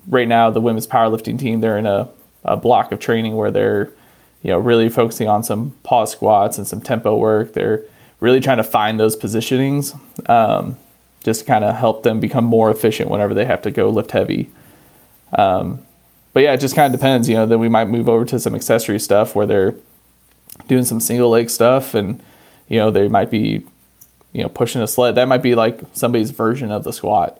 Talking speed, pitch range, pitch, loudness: 210 wpm, 110-125 Hz, 115 Hz, -16 LUFS